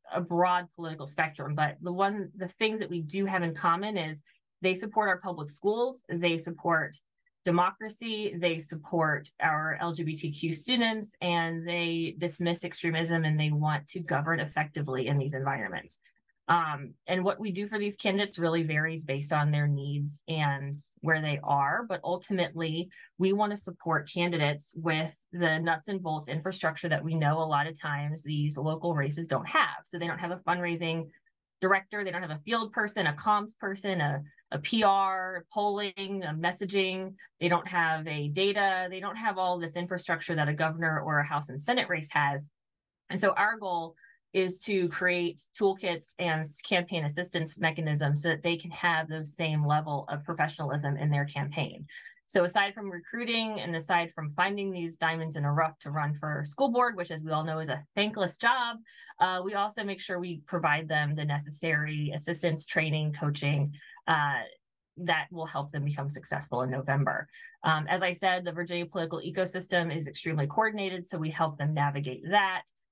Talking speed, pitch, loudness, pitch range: 180 wpm, 165 Hz, -30 LUFS, 150-185 Hz